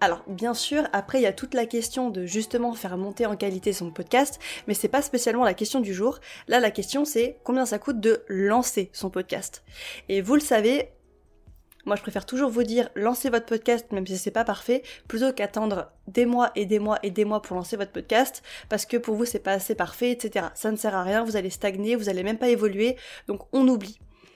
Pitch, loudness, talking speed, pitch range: 220 Hz, -26 LUFS, 230 wpm, 200-245 Hz